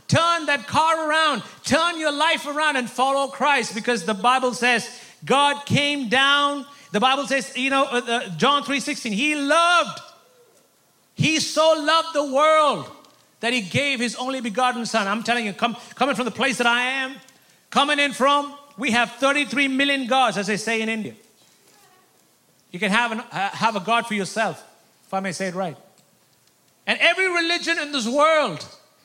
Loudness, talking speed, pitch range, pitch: -21 LUFS, 180 wpm, 235-290 Hz, 265 Hz